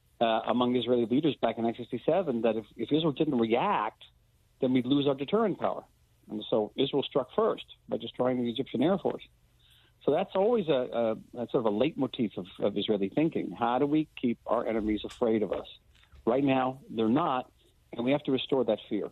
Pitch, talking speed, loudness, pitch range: 120 Hz, 205 wpm, -29 LUFS, 115-140 Hz